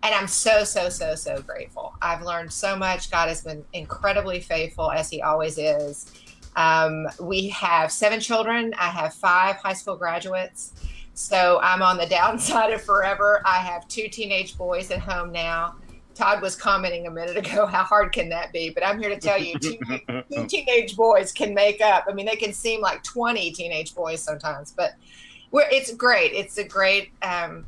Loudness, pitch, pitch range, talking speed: -22 LUFS, 185 Hz, 170-210 Hz, 190 wpm